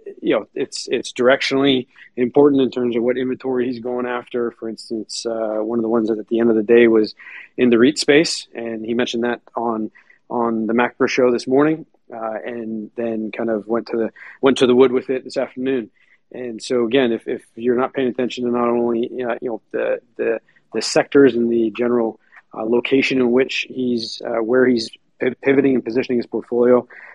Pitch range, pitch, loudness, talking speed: 115-130 Hz, 120 Hz, -19 LUFS, 210 wpm